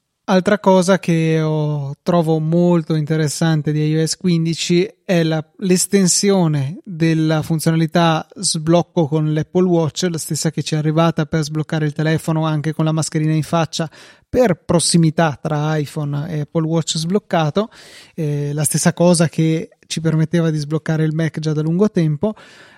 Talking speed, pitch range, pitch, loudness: 150 wpm, 155-175 Hz, 160 Hz, -17 LUFS